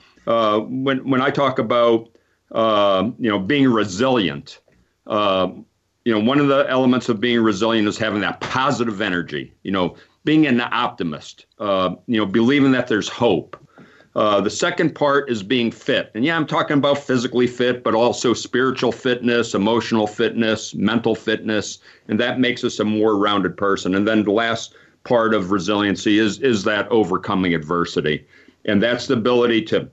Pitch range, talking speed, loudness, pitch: 105-130 Hz, 170 wpm, -19 LUFS, 115 Hz